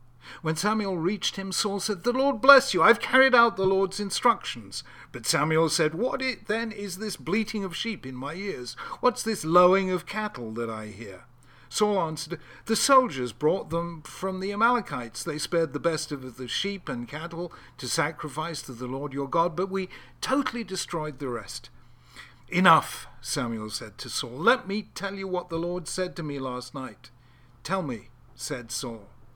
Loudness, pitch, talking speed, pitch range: -26 LUFS, 170 Hz, 185 wpm, 130-205 Hz